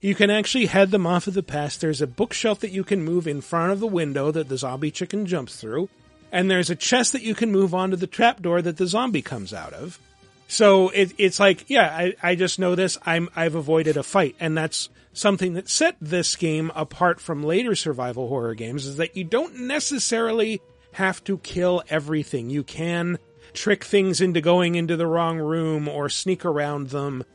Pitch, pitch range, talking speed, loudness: 175 Hz, 155-195 Hz, 210 wpm, -22 LUFS